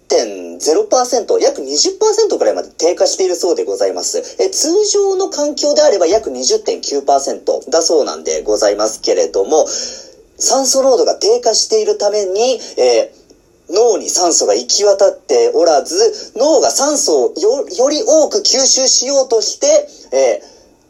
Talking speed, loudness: 280 characters per minute, -13 LUFS